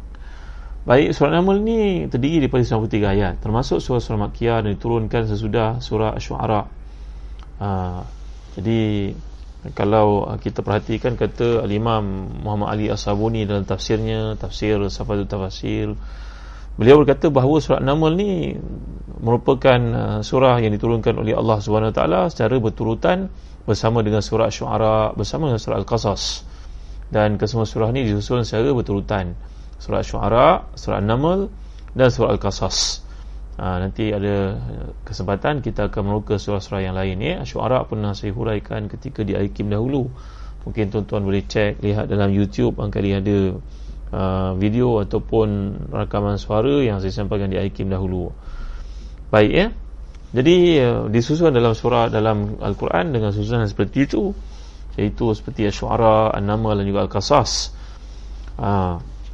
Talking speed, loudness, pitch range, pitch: 130 wpm, -20 LUFS, 100-115 Hz, 105 Hz